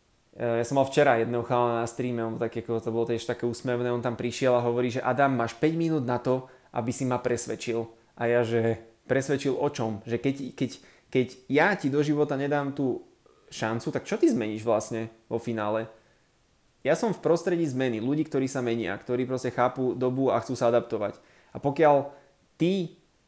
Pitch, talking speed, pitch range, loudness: 125 Hz, 195 wpm, 115-140 Hz, -27 LUFS